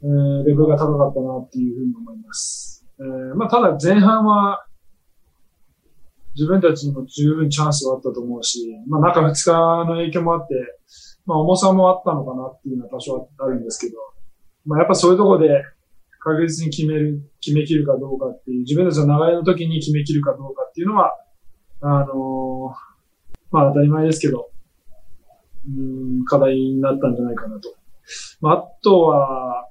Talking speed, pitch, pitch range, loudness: 360 characters per minute, 145 Hz, 130-165 Hz, -18 LUFS